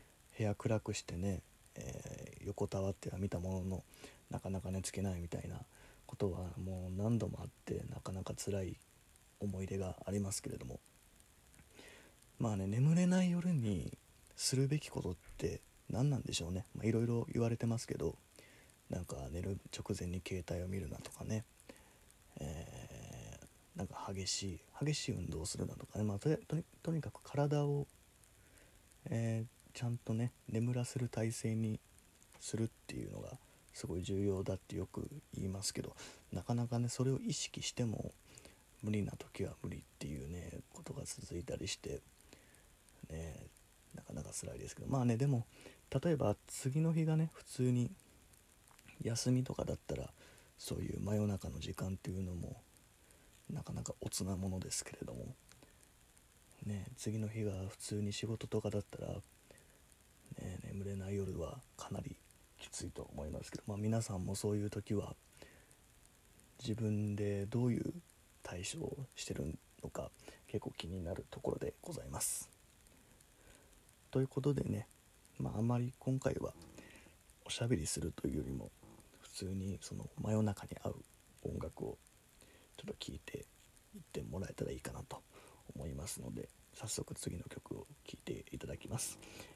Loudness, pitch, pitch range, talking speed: -41 LUFS, 105 Hz, 95-125 Hz, 300 characters per minute